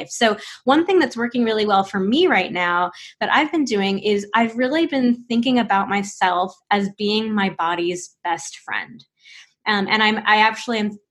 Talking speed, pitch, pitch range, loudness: 185 wpm, 210 Hz, 195-235 Hz, -19 LUFS